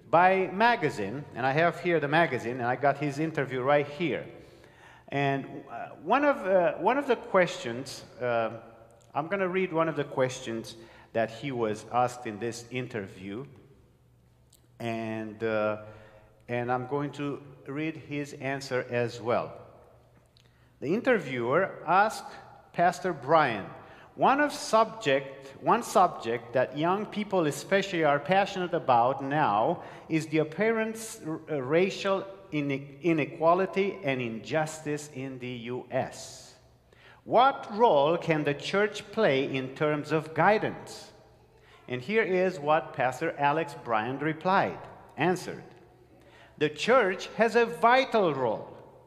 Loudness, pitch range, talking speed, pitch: -28 LUFS, 125-185 Hz, 125 wpm, 150 Hz